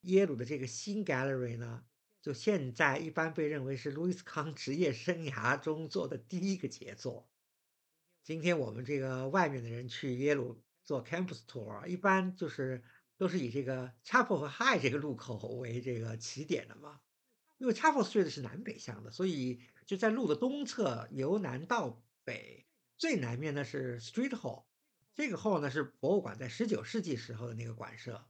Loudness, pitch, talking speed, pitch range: -36 LUFS, 145 Hz, 345 characters per minute, 125-185 Hz